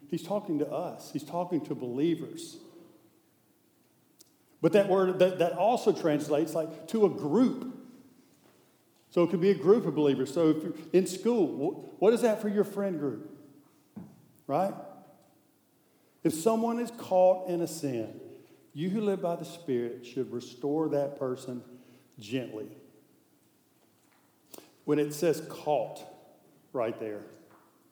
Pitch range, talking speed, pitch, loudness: 140-200 Hz, 140 wpm, 165 Hz, -29 LUFS